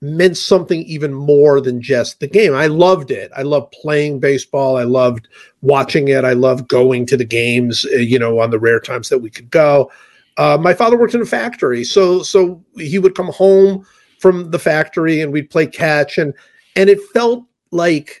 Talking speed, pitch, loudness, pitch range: 200 wpm, 155 Hz, -14 LUFS, 135-185 Hz